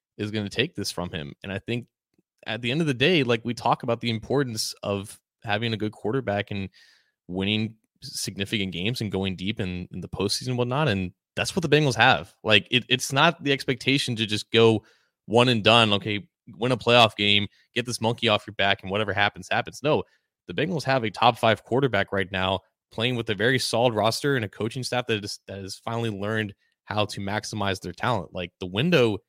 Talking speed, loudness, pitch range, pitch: 220 wpm, -24 LUFS, 100-125 Hz, 110 Hz